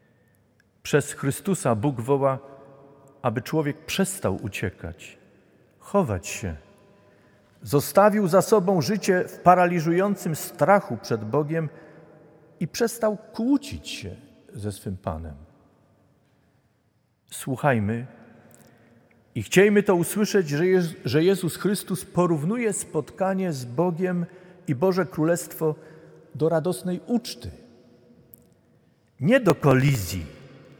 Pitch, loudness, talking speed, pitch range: 160 Hz, -24 LUFS, 90 wpm, 130-185 Hz